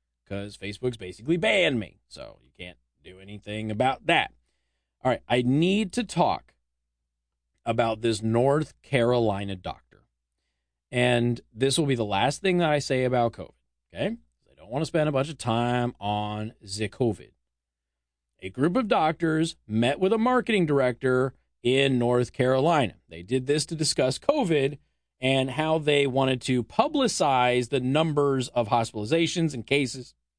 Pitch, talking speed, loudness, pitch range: 125 Hz, 155 wpm, -25 LUFS, 100-145 Hz